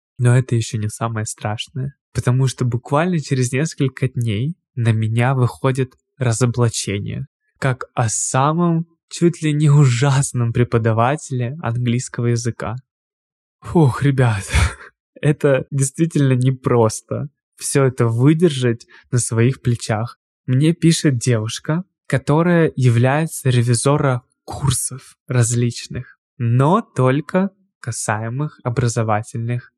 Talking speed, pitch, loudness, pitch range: 100 wpm, 130 Hz, -18 LUFS, 120-145 Hz